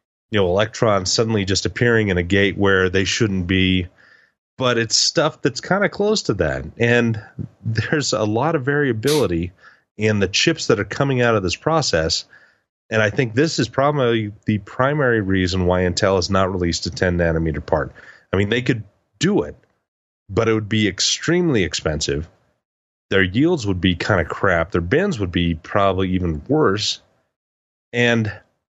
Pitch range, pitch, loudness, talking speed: 90-120 Hz, 105 Hz, -19 LUFS, 175 wpm